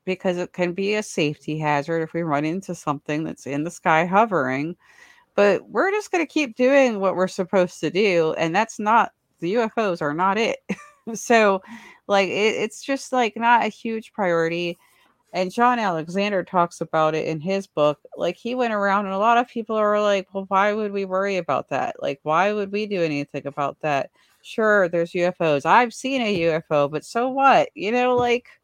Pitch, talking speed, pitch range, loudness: 195 Hz, 195 wpm, 165-230 Hz, -22 LUFS